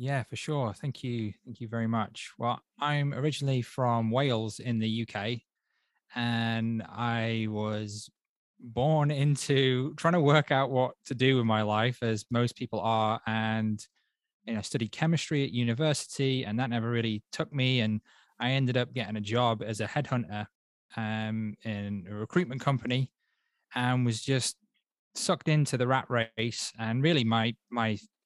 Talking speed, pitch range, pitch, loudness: 160 wpm, 110-135 Hz, 120 Hz, -30 LUFS